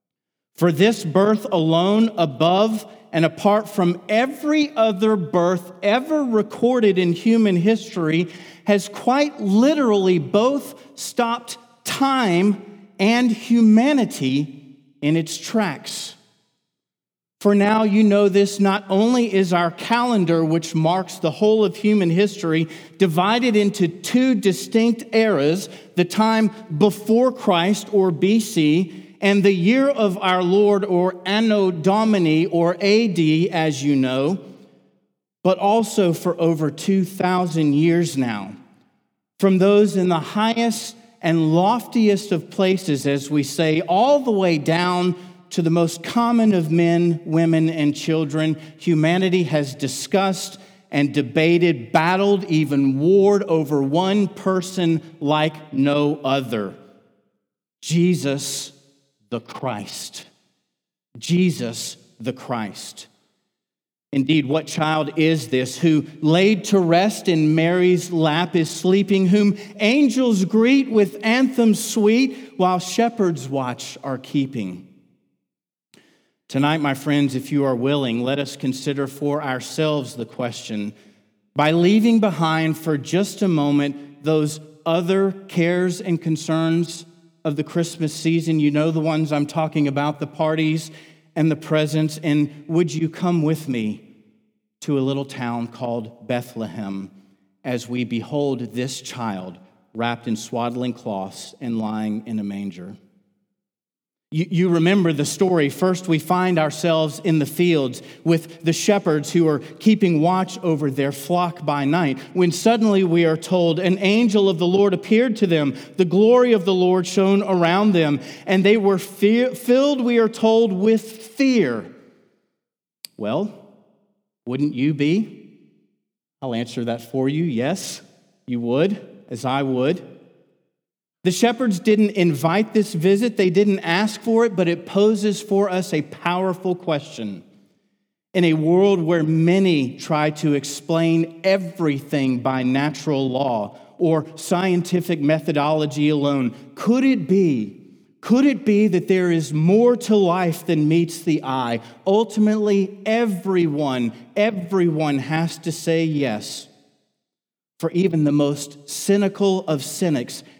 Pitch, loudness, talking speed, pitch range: 170 Hz, -19 LUFS, 130 wpm, 150-200 Hz